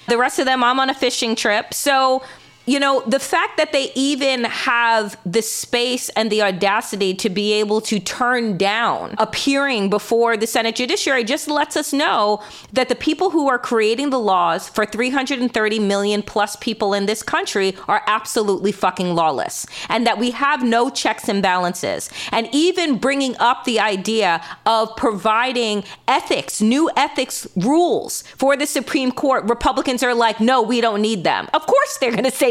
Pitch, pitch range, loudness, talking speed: 235 Hz, 210-270 Hz, -18 LUFS, 175 wpm